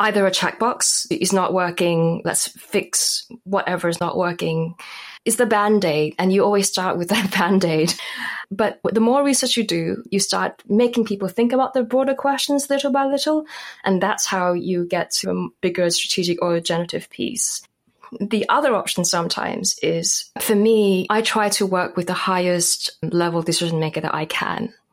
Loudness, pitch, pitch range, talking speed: -20 LUFS, 190 Hz, 175-225 Hz, 180 wpm